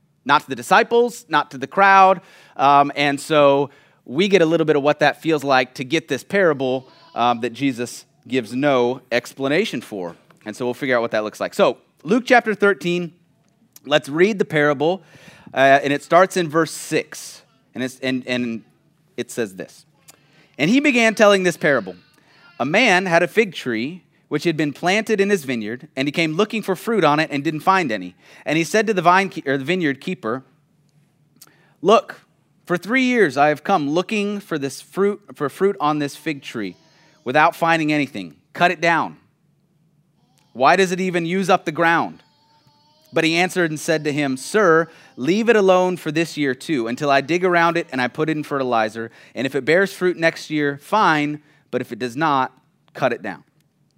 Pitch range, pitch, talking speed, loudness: 140-180 Hz, 155 Hz, 200 wpm, -19 LUFS